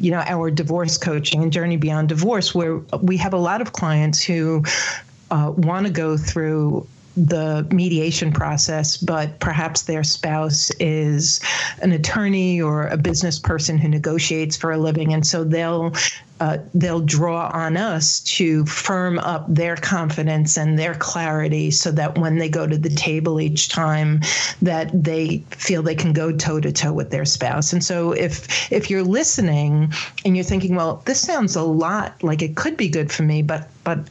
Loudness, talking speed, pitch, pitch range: -19 LUFS, 180 wpm, 160 Hz, 155-175 Hz